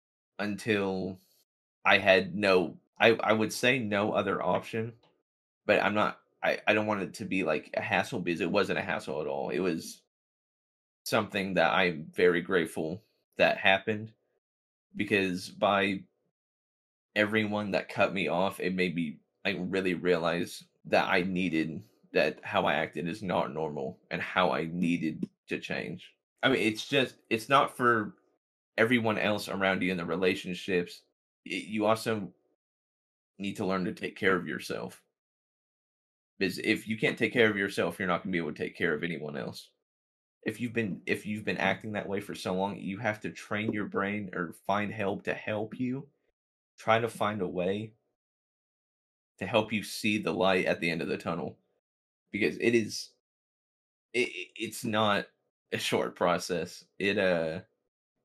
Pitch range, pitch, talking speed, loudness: 90-110 Hz, 100 Hz, 170 wpm, -30 LUFS